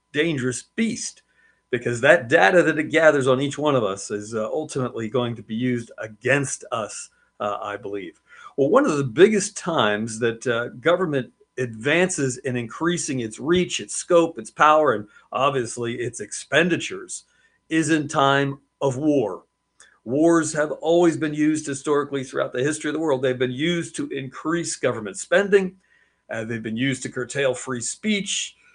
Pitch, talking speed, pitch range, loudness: 145 Hz, 165 wpm, 125-170 Hz, -22 LUFS